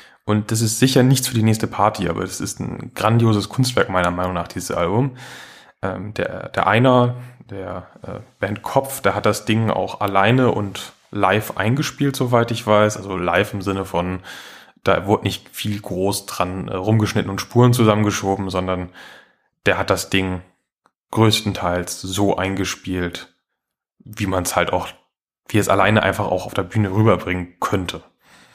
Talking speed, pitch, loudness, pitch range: 160 wpm, 100 Hz, -19 LUFS, 95-110 Hz